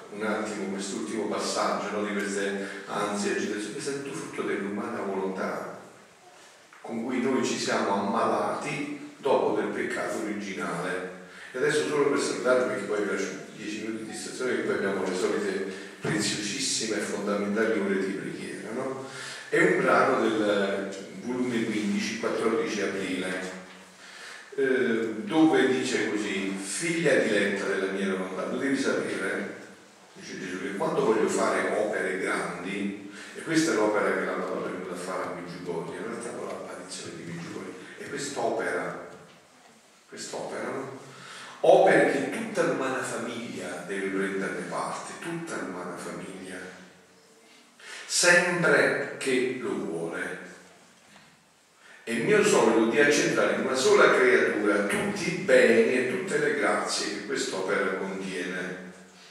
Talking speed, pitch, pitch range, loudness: 140 wpm, 100 Hz, 95-110 Hz, -27 LUFS